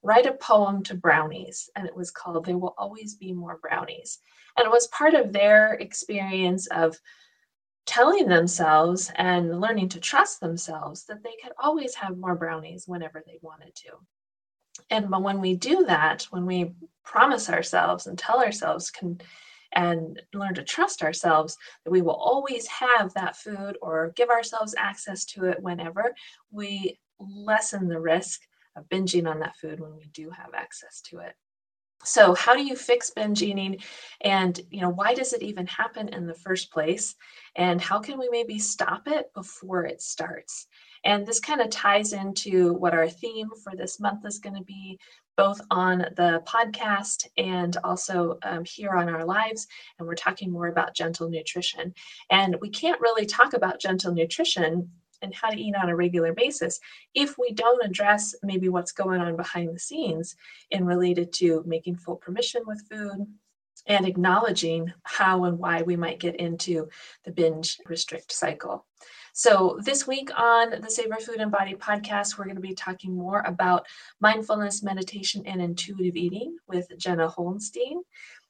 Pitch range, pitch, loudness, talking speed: 170-215 Hz, 185 Hz, -25 LUFS, 170 wpm